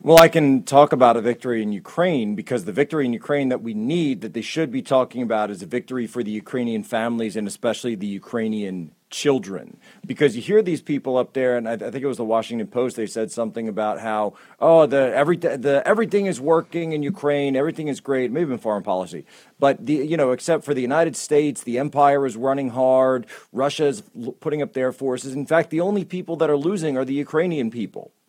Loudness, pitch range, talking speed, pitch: -21 LUFS, 115-150 Hz, 210 wpm, 135 Hz